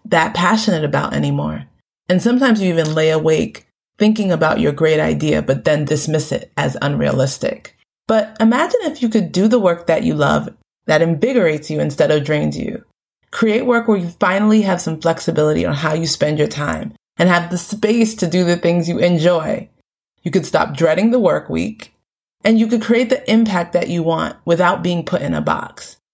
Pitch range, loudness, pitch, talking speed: 160-220 Hz, -16 LUFS, 175 Hz, 195 wpm